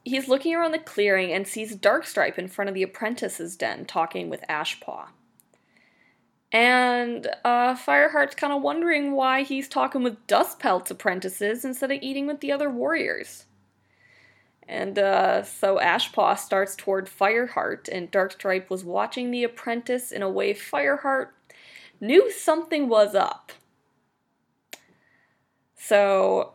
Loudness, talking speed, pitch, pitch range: -24 LUFS, 135 wpm, 245 Hz, 200-280 Hz